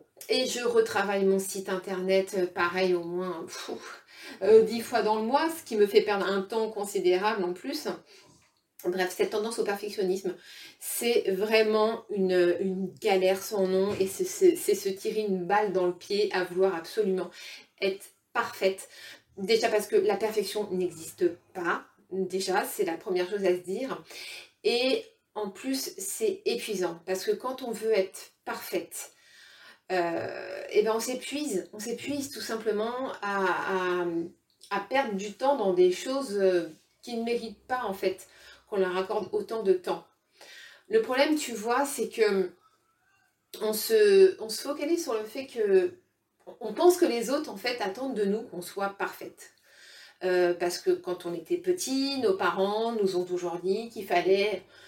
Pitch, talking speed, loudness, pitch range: 210 Hz, 170 wpm, -28 LUFS, 190-265 Hz